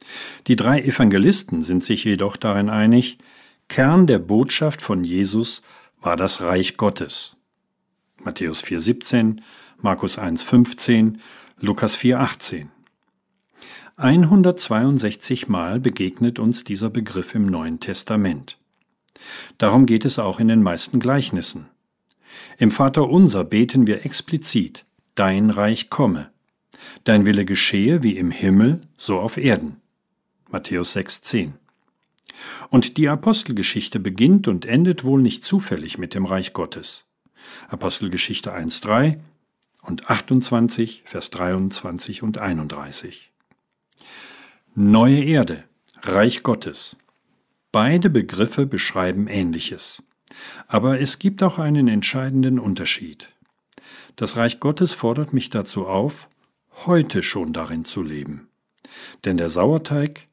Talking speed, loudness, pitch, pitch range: 110 wpm, -19 LUFS, 115 Hz, 100-135 Hz